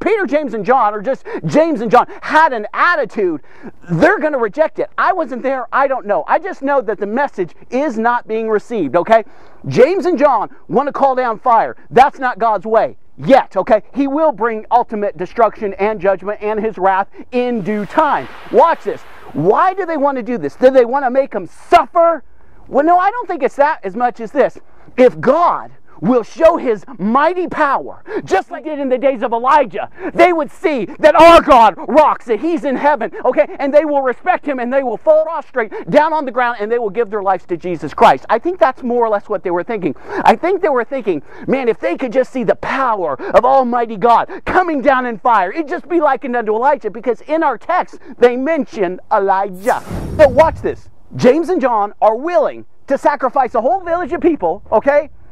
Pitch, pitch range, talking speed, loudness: 265 Hz, 225-315 Hz, 215 wpm, -14 LUFS